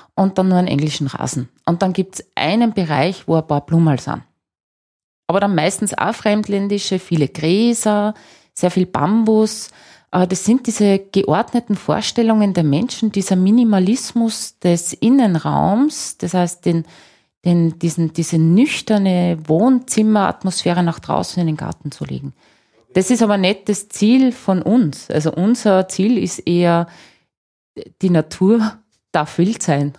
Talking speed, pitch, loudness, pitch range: 145 wpm, 190 Hz, -17 LUFS, 165-215 Hz